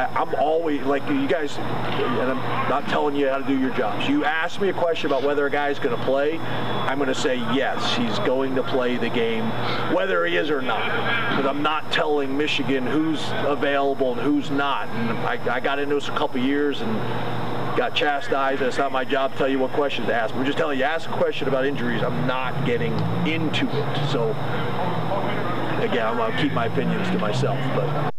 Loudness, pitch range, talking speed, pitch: -23 LUFS, 130-145 Hz, 215 wpm, 140 Hz